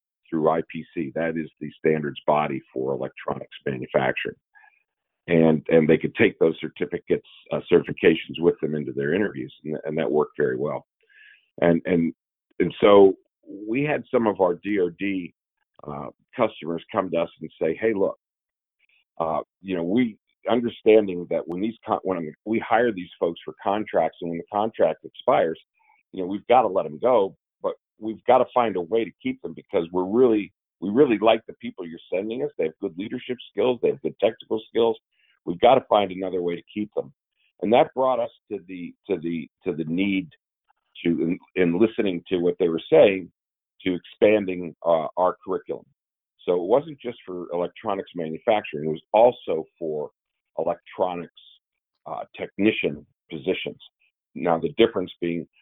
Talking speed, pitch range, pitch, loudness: 175 wpm, 85-115 Hz, 90 Hz, -24 LUFS